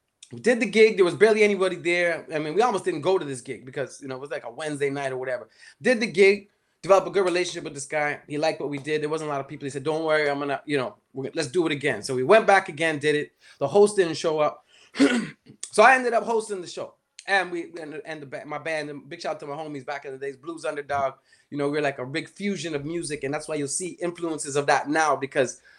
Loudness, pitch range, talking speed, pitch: -24 LUFS, 145-185 Hz, 290 wpm, 155 Hz